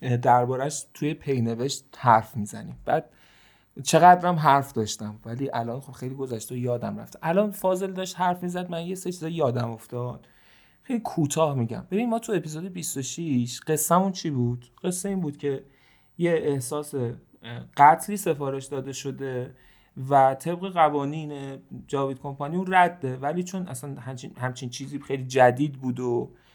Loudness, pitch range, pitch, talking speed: -25 LUFS, 125-170 Hz, 140 Hz, 150 wpm